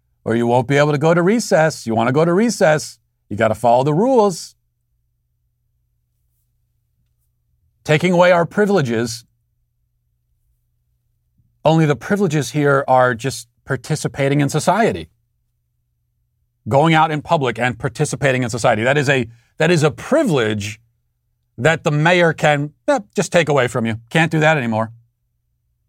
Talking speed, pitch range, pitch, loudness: 145 wpm, 115-155 Hz, 125 Hz, -16 LUFS